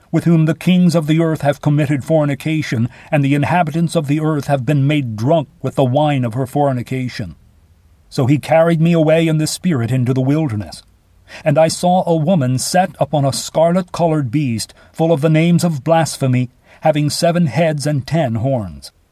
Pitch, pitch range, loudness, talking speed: 150 Hz, 130-165 Hz, -16 LUFS, 190 wpm